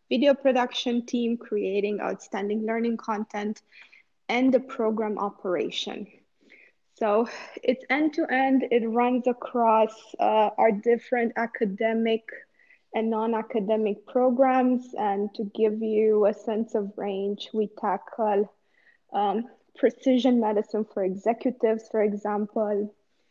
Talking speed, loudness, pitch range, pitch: 115 wpm, -26 LUFS, 210-245 Hz, 225 Hz